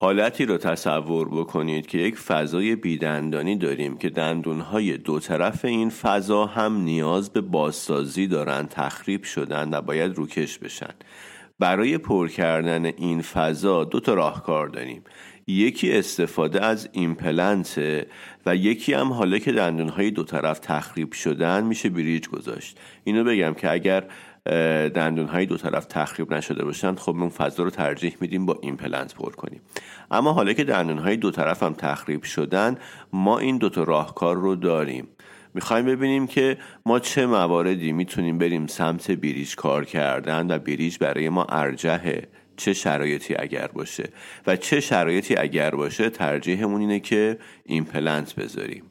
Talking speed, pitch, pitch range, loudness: 145 wpm, 85 Hz, 80-100 Hz, -24 LUFS